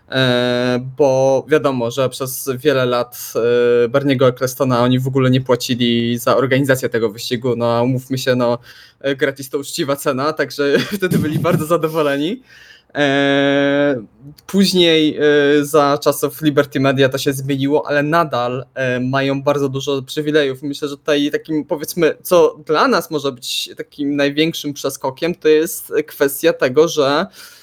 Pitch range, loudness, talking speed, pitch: 130-150 Hz, -16 LUFS, 135 wpm, 140 Hz